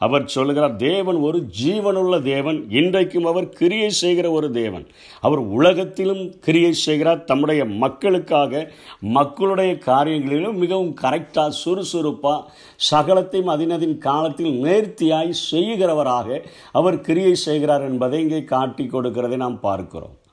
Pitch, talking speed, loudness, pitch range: 155 Hz, 110 wpm, -19 LUFS, 140-180 Hz